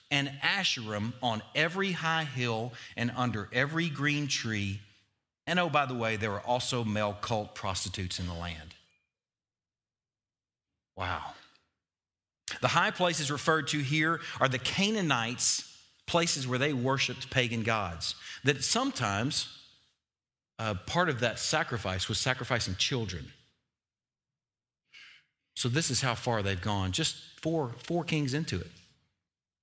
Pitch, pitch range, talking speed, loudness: 125 Hz, 105-150 Hz, 130 wpm, -30 LUFS